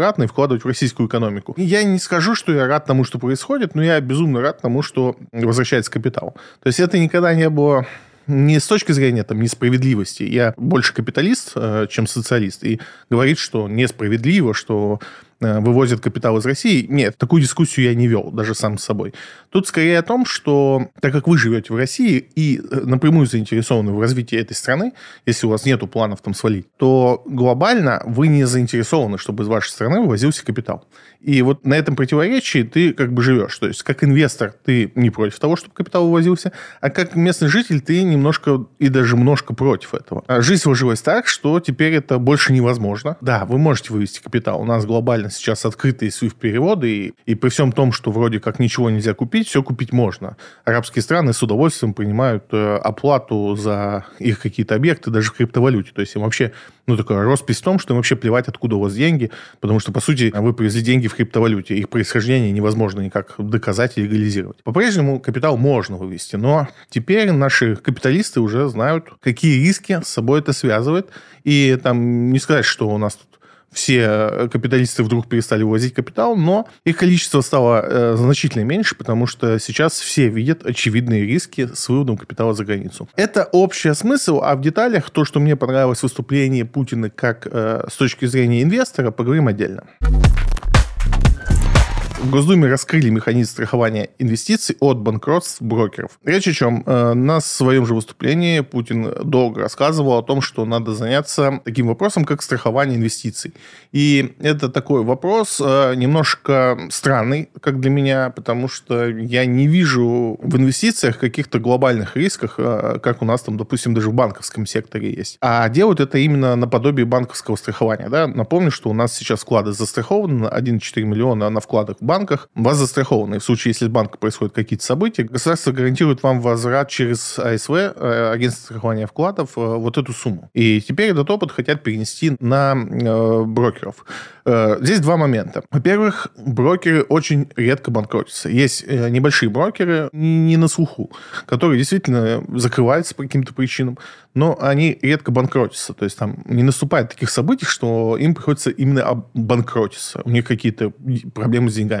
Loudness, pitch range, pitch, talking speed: -17 LUFS, 115-145 Hz, 125 Hz, 170 wpm